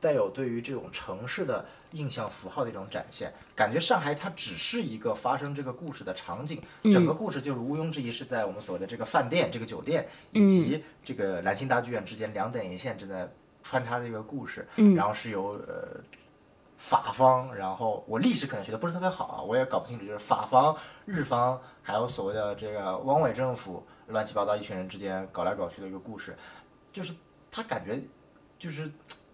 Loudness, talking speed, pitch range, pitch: -30 LUFS, 315 characters per minute, 110-155 Hz, 130 Hz